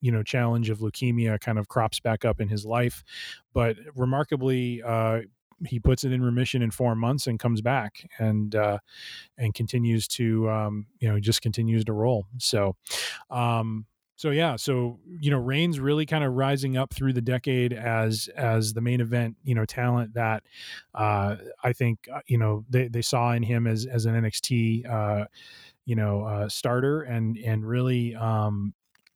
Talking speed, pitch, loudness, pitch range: 180 wpm, 115 Hz, -26 LUFS, 110-125 Hz